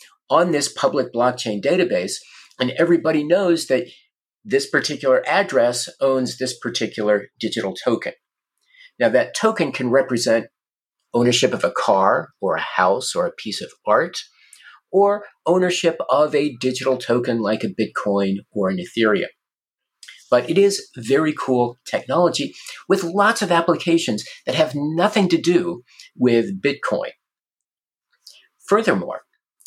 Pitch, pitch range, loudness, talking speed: 140 Hz, 120-175 Hz, -20 LUFS, 130 wpm